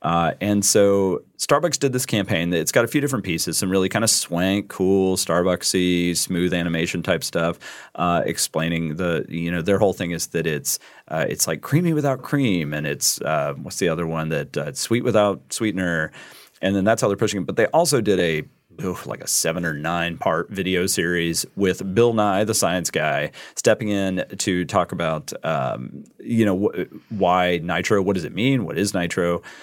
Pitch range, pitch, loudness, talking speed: 85-105 Hz, 95 Hz, -21 LUFS, 195 wpm